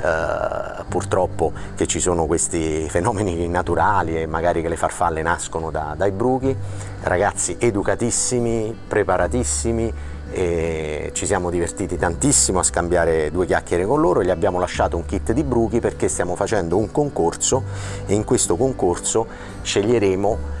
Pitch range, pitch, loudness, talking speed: 80-110 Hz, 95 Hz, -20 LUFS, 140 wpm